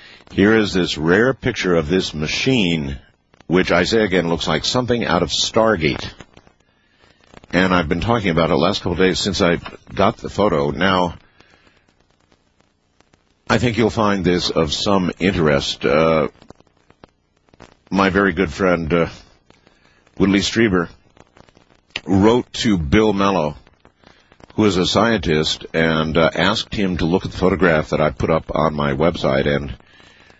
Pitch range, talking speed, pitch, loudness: 80-100 Hz, 150 wpm, 90 Hz, -17 LUFS